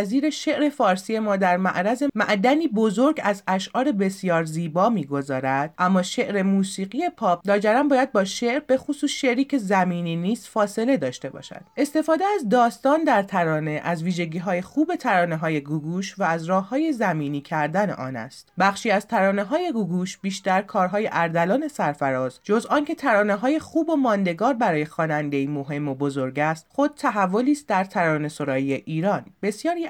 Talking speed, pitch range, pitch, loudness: 160 wpm, 170-245 Hz, 195 Hz, -23 LUFS